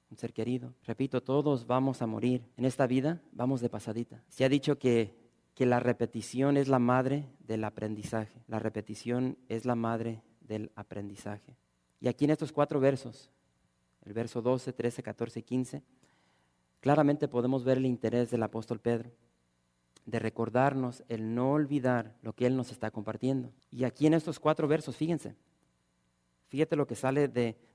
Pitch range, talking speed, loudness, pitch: 110-130 Hz, 165 wpm, -32 LUFS, 120 Hz